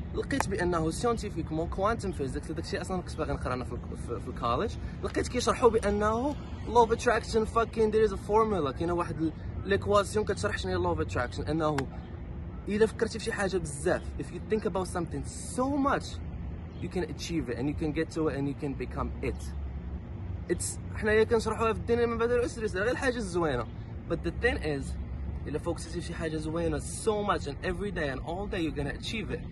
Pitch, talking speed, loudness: 165 Hz, 200 wpm, -31 LUFS